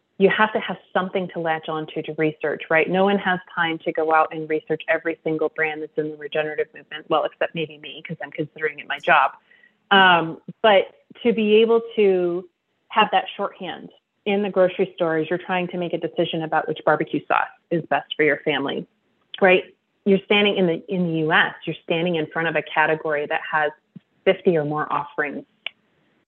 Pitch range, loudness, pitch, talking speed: 155-190 Hz, -21 LUFS, 165 Hz, 200 wpm